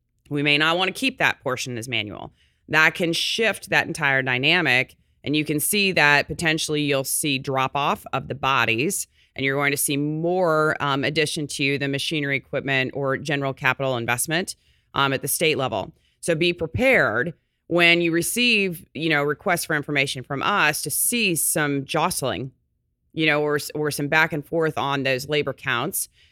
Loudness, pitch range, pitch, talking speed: -21 LUFS, 135-165 Hz, 150 Hz, 180 wpm